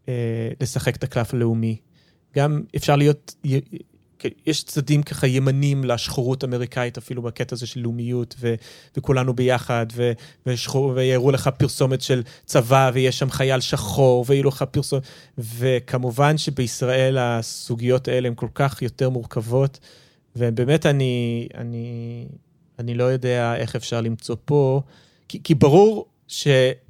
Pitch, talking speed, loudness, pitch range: 130 Hz, 130 wpm, -21 LUFS, 120-140 Hz